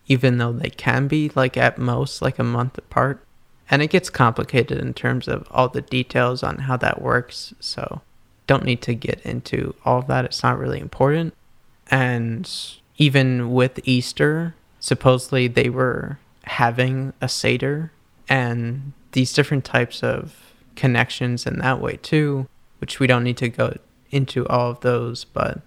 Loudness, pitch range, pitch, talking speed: -21 LUFS, 120-135 Hz, 125 Hz, 165 wpm